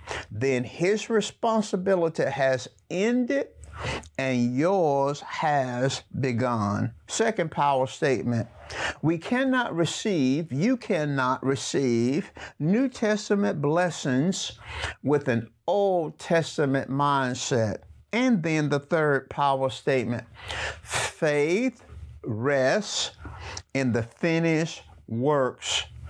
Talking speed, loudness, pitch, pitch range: 85 wpm, -26 LUFS, 140 Hz, 125-170 Hz